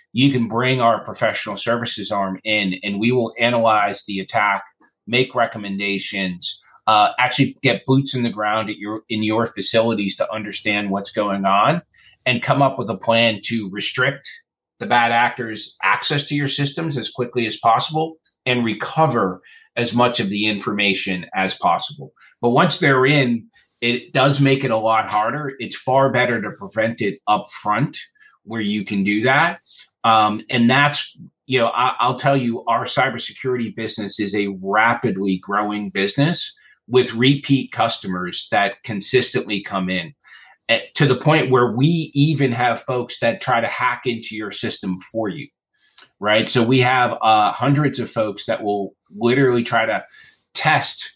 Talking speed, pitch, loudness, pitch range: 165 wpm, 115 Hz, -19 LUFS, 105-130 Hz